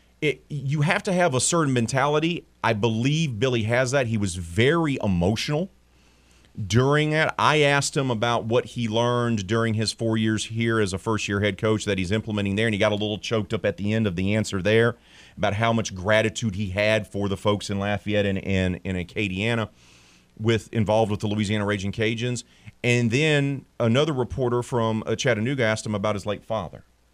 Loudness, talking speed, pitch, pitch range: -24 LUFS, 195 wpm, 110 Hz, 105-120 Hz